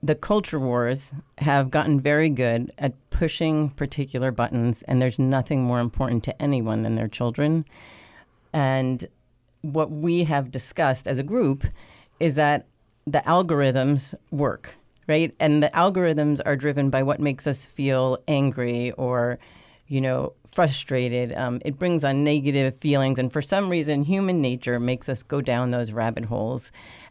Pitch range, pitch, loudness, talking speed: 125-150 Hz, 135 Hz, -24 LUFS, 155 wpm